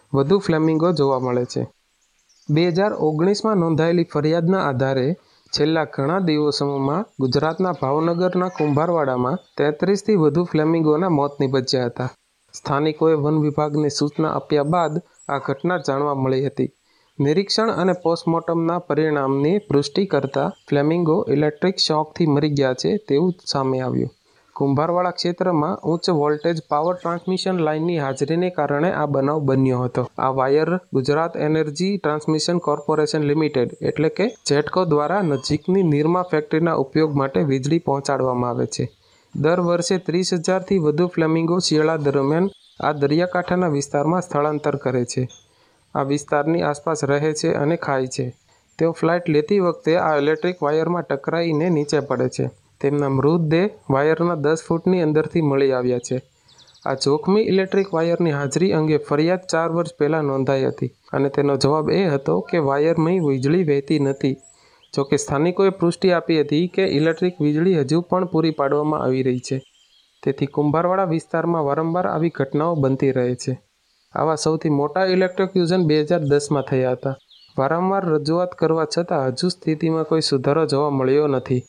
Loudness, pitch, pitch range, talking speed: -20 LUFS, 155 Hz, 140-170 Hz, 140 wpm